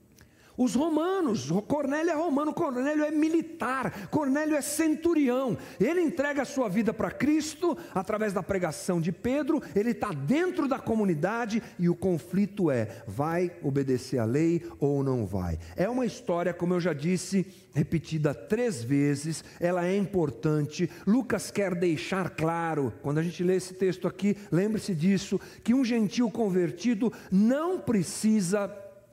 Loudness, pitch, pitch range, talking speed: -28 LUFS, 195 Hz, 170-255 Hz, 150 wpm